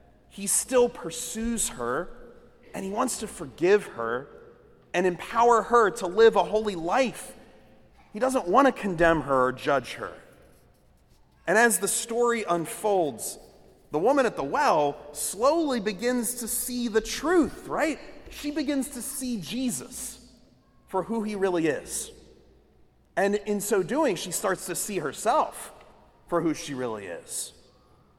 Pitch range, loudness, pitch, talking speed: 180-250 Hz, -26 LUFS, 225 Hz, 145 wpm